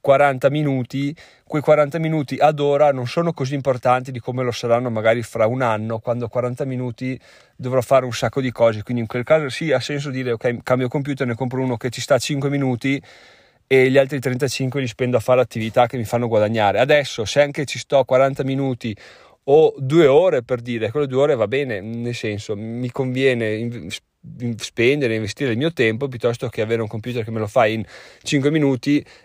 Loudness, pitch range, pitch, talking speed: -20 LUFS, 120-140 Hz, 130 Hz, 200 wpm